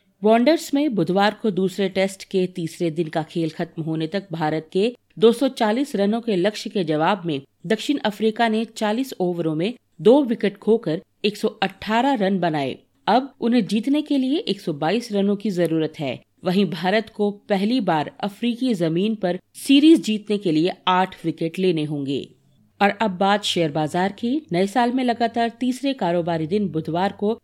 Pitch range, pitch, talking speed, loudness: 175-230 Hz, 200 Hz, 165 wpm, -21 LUFS